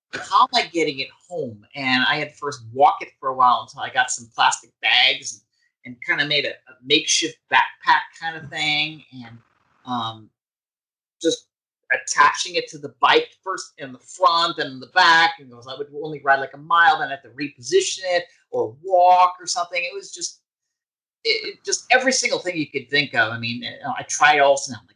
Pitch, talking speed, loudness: 160 Hz, 210 wpm, -20 LUFS